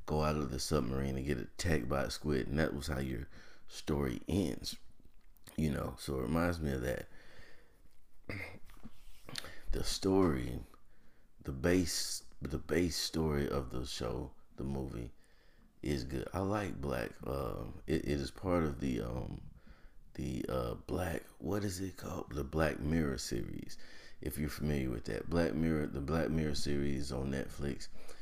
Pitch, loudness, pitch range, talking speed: 75 Hz, -37 LUFS, 65-80 Hz, 160 wpm